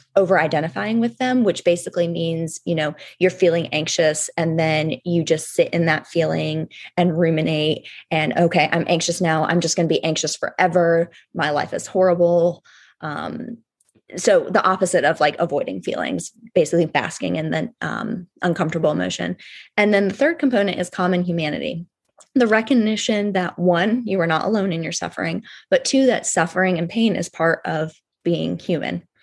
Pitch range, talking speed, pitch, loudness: 165-200 Hz, 170 wpm, 175 Hz, -20 LUFS